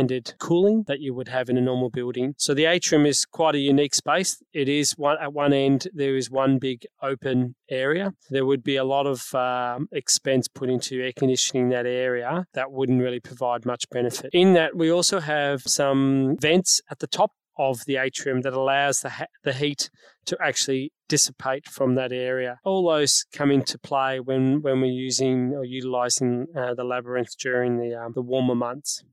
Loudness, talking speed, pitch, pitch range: -23 LUFS, 195 wpm, 135 Hz, 125-145 Hz